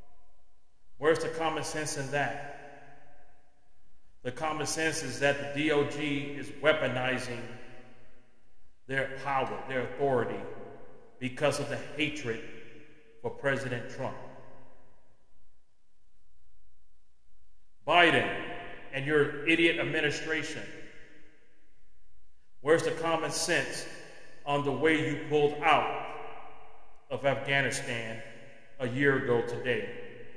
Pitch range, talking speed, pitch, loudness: 120-150 Hz, 95 wpm, 140 Hz, -30 LUFS